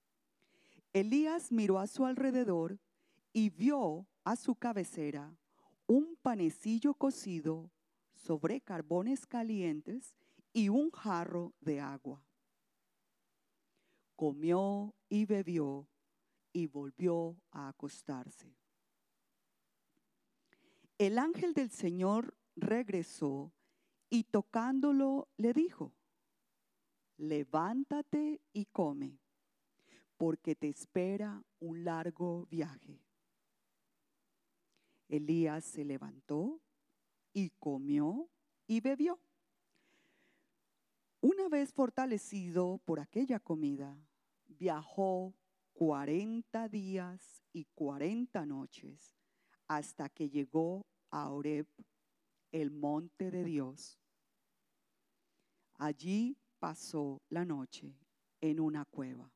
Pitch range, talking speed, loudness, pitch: 155-245 Hz, 80 wpm, -37 LUFS, 185 Hz